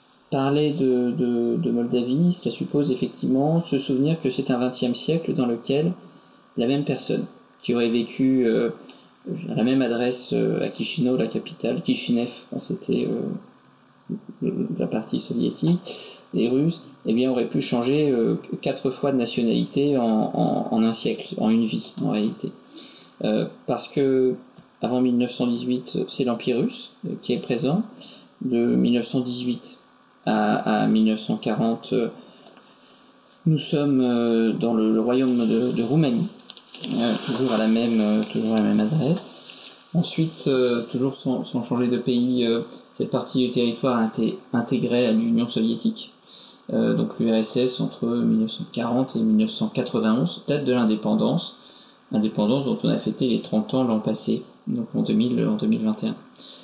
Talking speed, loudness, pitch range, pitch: 145 wpm, -23 LUFS, 120-175 Hz, 130 Hz